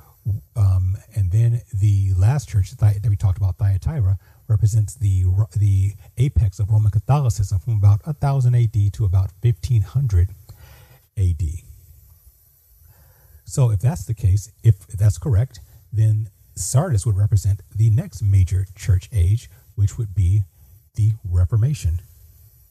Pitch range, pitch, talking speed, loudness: 95-110 Hz, 105 Hz, 125 wpm, -20 LUFS